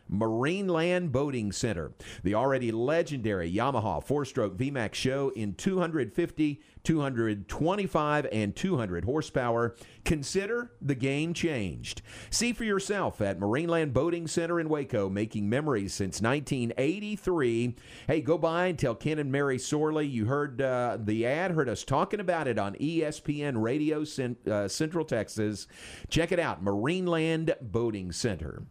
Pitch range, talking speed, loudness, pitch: 110-165 Hz, 140 wpm, -30 LUFS, 135 Hz